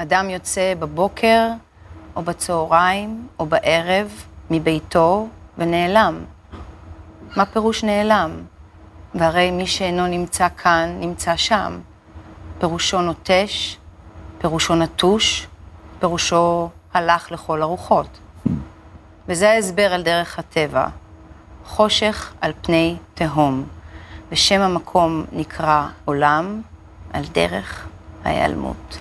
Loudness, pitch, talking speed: -19 LUFS, 165 Hz, 90 wpm